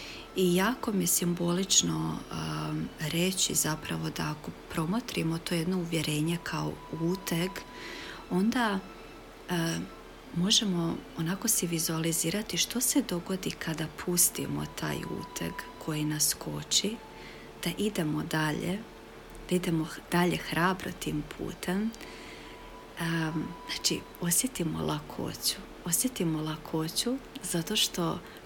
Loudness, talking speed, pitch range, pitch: -30 LUFS, 105 wpm, 155-185 Hz, 170 Hz